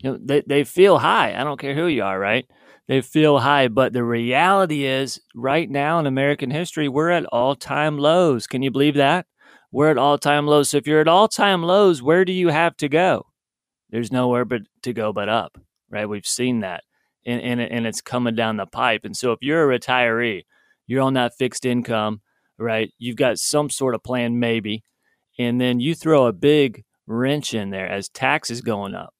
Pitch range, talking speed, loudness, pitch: 120-150 Hz, 210 wpm, -20 LUFS, 130 Hz